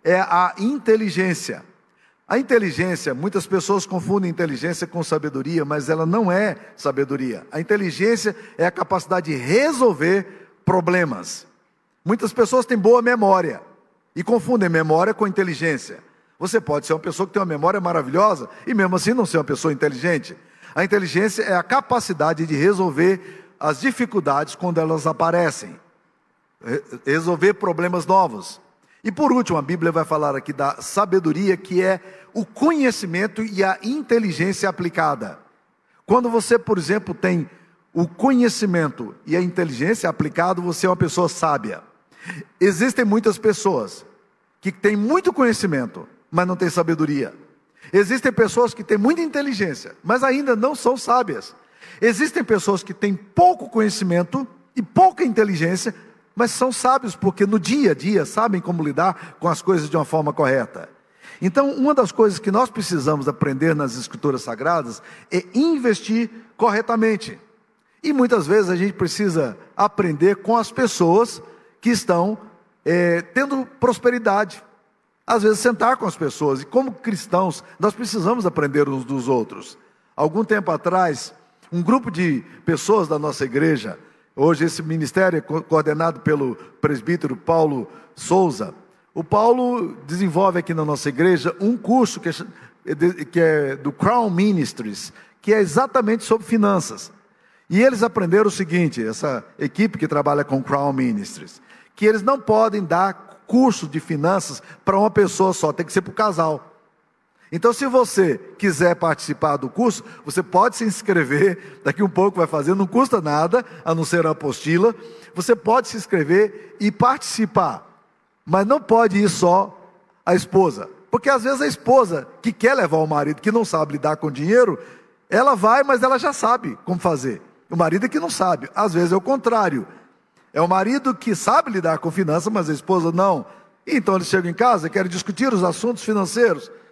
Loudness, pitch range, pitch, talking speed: -20 LUFS, 165-225 Hz, 190 Hz, 160 wpm